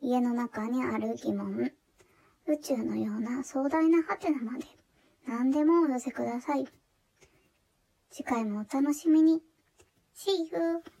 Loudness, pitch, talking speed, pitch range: -30 LUFS, 275 Hz, 250 characters per minute, 240-320 Hz